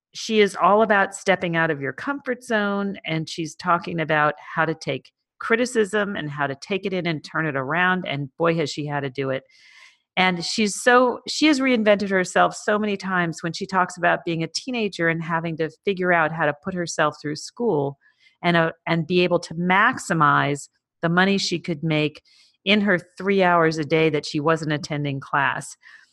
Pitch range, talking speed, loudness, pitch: 155-200 Hz, 200 wpm, -22 LUFS, 175 Hz